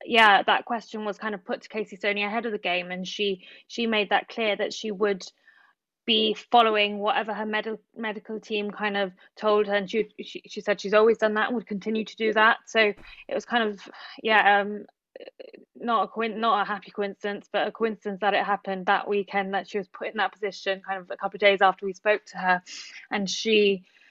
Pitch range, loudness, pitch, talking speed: 200-220 Hz, -25 LUFS, 210 Hz, 225 wpm